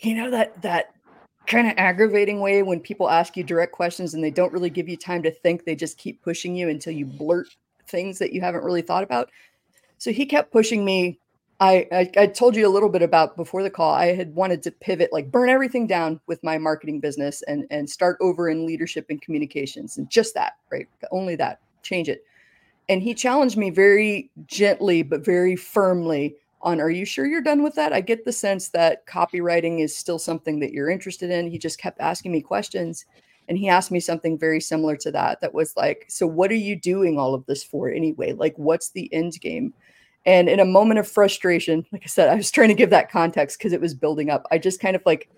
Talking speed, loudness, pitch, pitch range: 230 wpm, -21 LUFS, 180 Hz, 165-205 Hz